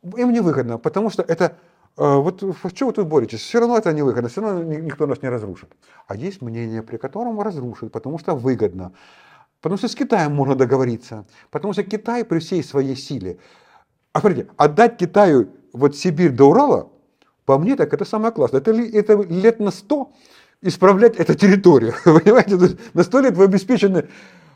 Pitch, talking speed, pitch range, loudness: 180 Hz, 185 wpm, 135-210 Hz, -17 LUFS